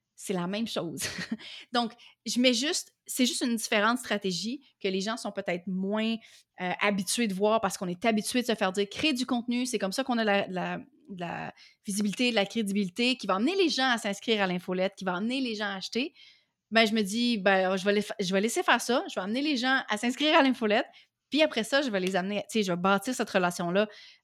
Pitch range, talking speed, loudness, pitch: 195-250 Hz, 245 wpm, -28 LUFS, 220 Hz